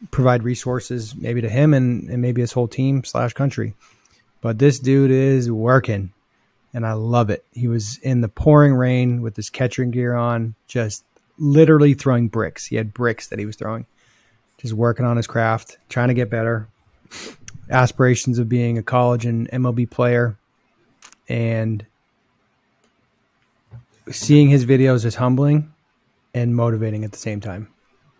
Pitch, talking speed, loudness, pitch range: 120 Hz, 155 wpm, -19 LUFS, 115-130 Hz